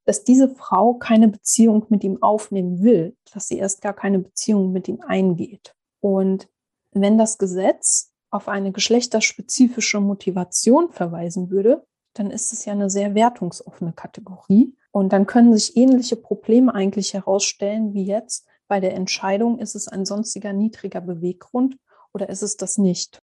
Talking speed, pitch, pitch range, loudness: 155 wpm, 205 Hz, 195-225 Hz, -19 LUFS